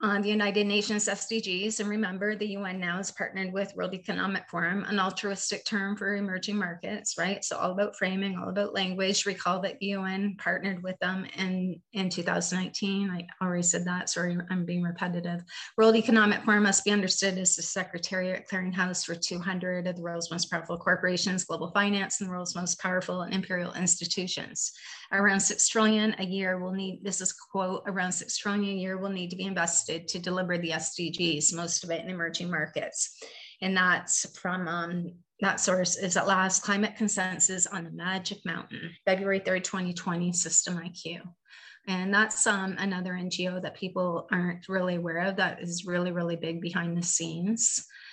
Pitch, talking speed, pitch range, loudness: 185 Hz, 180 wpm, 175-200 Hz, -28 LUFS